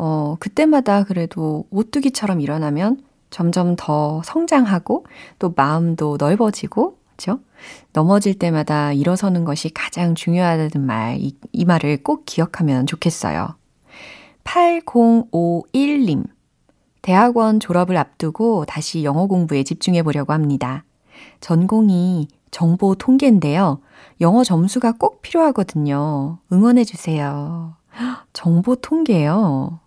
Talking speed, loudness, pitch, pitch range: 255 characters per minute, -18 LUFS, 175 Hz, 155-225 Hz